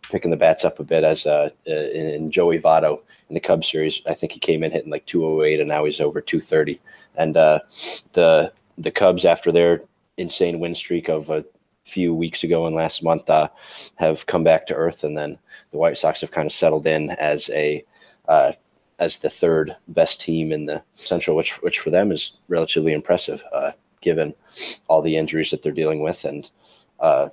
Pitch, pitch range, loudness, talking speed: 80 Hz, 75-85 Hz, -20 LUFS, 200 wpm